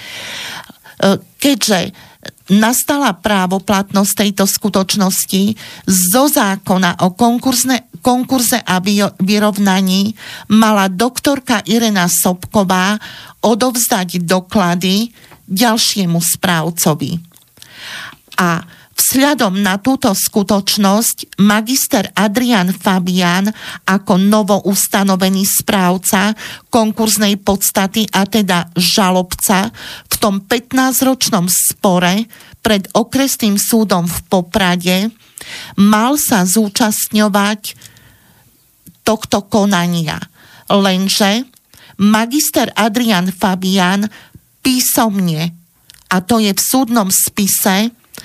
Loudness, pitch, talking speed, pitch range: -13 LUFS, 205 Hz, 75 wpm, 185-225 Hz